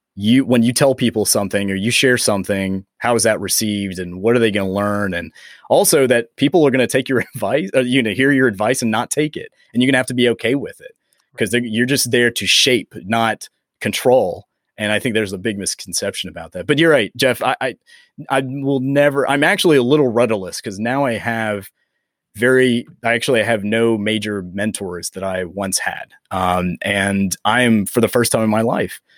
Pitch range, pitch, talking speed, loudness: 100-125 Hz, 115 Hz, 220 wpm, -17 LUFS